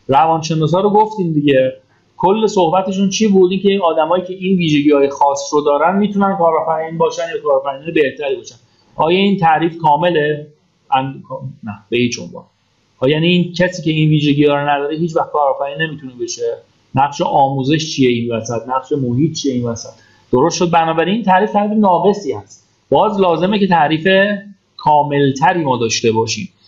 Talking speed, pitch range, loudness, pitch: 165 wpm, 135-185 Hz, -15 LUFS, 155 Hz